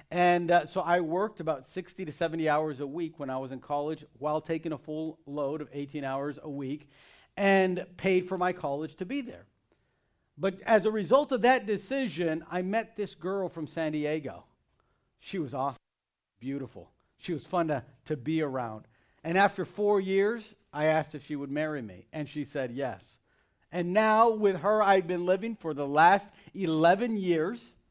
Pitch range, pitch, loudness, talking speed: 150-195 Hz, 165 Hz, -29 LUFS, 185 wpm